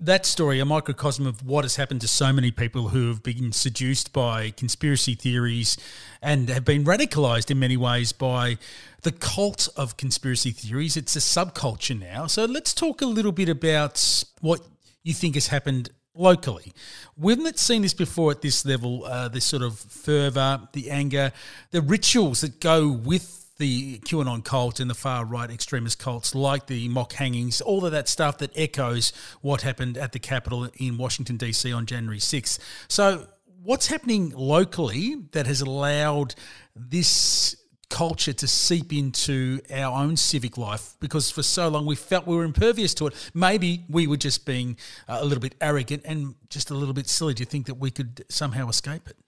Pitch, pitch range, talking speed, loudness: 140 Hz, 125-155 Hz, 185 wpm, -24 LUFS